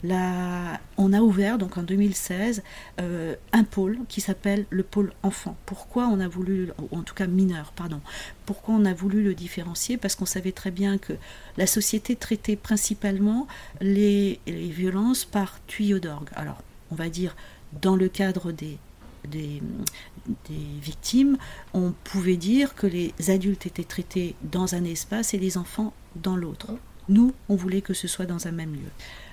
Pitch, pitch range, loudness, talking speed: 190 Hz, 175-205 Hz, -26 LUFS, 170 wpm